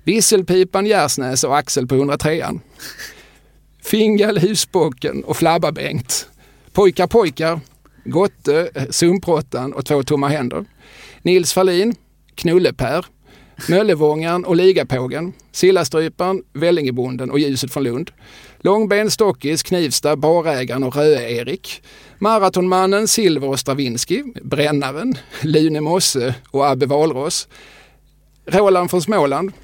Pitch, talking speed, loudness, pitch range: 160 Hz, 100 wpm, -17 LUFS, 140-185 Hz